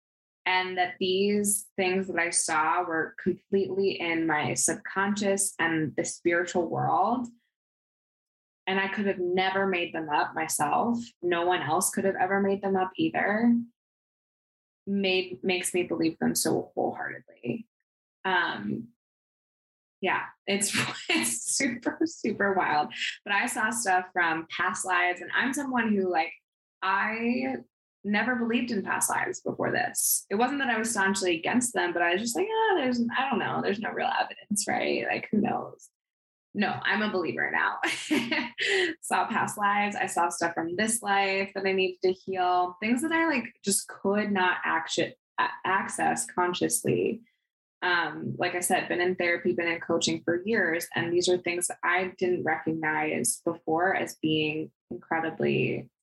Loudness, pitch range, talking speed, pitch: -27 LUFS, 175-220 Hz, 155 wpm, 190 Hz